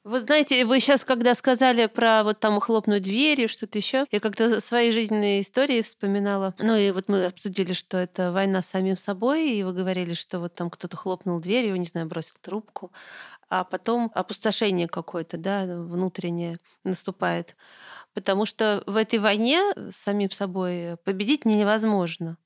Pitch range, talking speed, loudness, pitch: 185-225 Hz, 170 wpm, -24 LUFS, 200 Hz